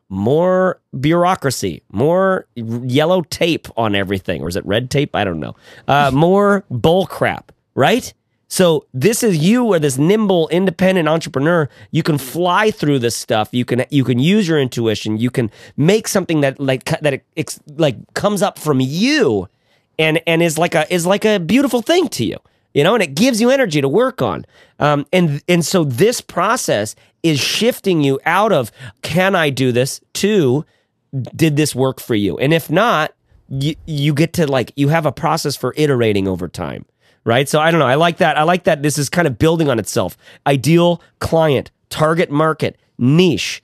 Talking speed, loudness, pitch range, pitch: 190 wpm, -16 LUFS, 130-175 Hz, 150 Hz